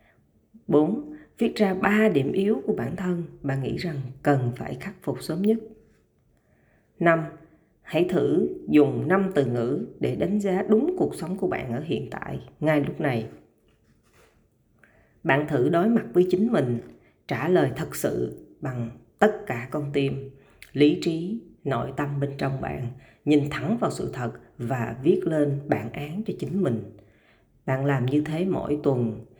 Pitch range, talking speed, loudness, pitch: 130-185 Hz, 165 wpm, -25 LUFS, 150 Hz